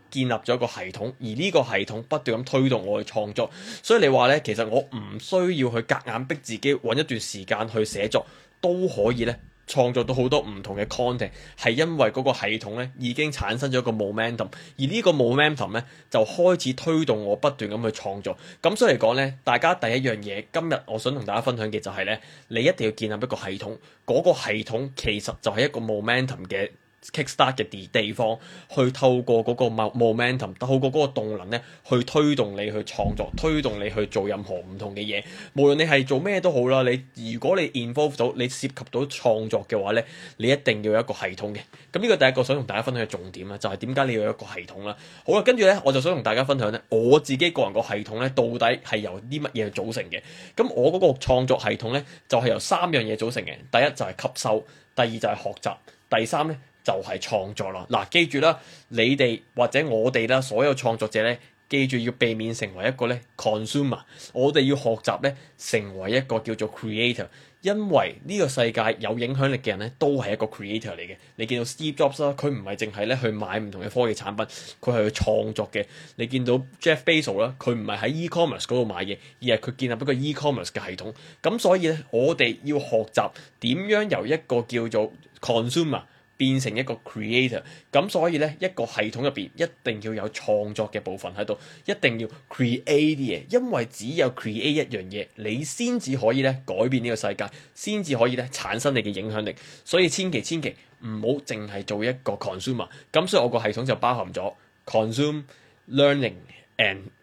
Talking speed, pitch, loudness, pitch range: 380 characters per minute, 125 Hz, -24 LUFS, 110-140 Hz